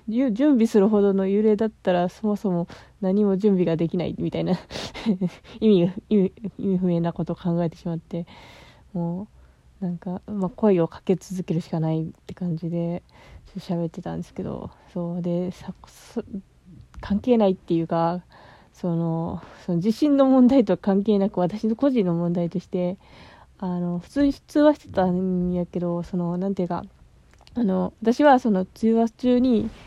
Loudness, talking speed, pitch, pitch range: -23 LUFS, 300 characters per minute, 185 Hz, 175-215 Hz